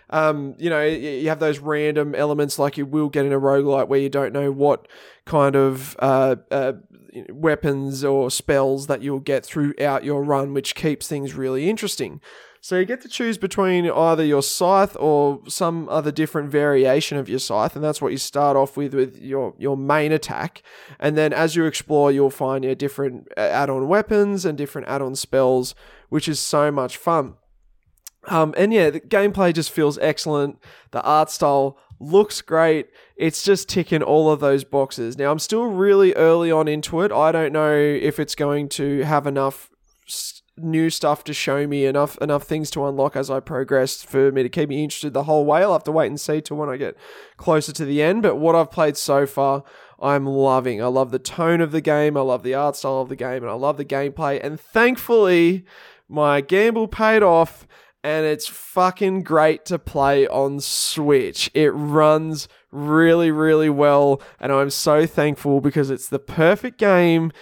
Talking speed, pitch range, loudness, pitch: 195 wpm, 140-160 Hz, -20 LUFS, 145 Hz